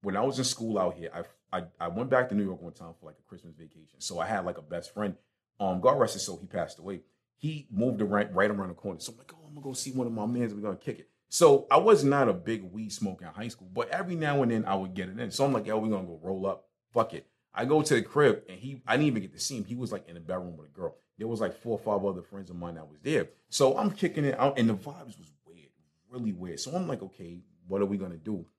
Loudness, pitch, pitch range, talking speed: -30 LUFS, 105 Hz, 95-130 Hz, 320 wpm